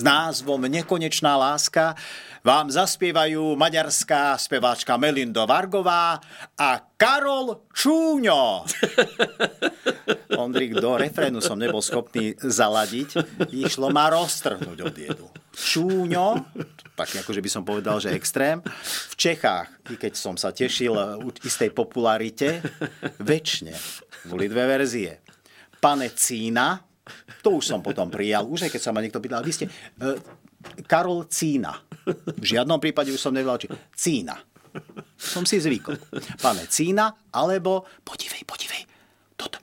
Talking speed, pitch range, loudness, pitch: 125 wpm, 130-175 Hz, -23 LUFS, 150 Hz